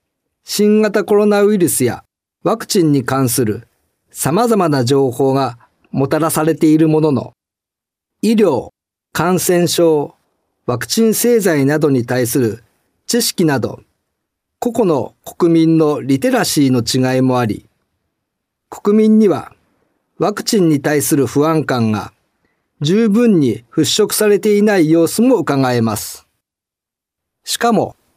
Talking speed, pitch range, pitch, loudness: 235 characters per minute, 130-205 Hz, 155 Hz, -14 LUFS